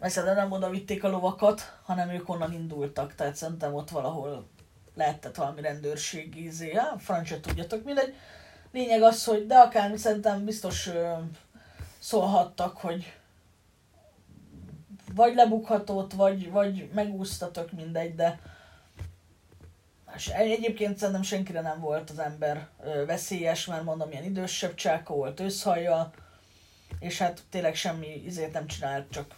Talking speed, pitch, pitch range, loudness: 130 wpm, 170 Hz, 150-195 Hz, -28 LUFS